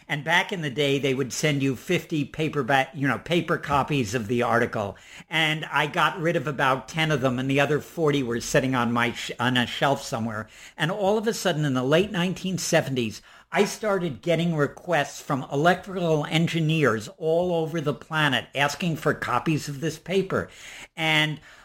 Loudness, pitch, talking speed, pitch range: -24 LUFS, 150 Hz, 190 wpm, 135-165 Hz